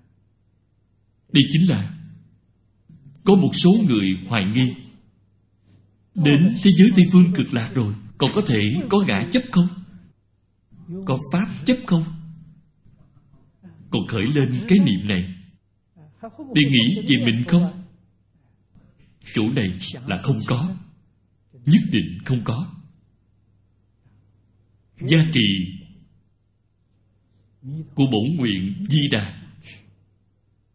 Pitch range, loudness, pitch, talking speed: 105-165 Hz, -19 LUFS, 125 Hz, 105 wpm